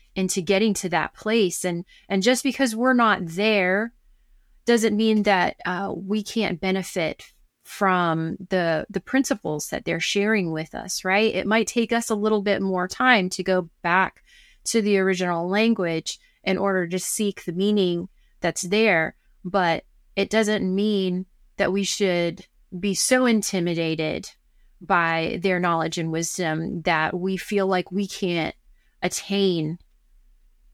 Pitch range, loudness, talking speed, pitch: 175-210 Hz, -23 LUFS, 145 wpm, 190 Hz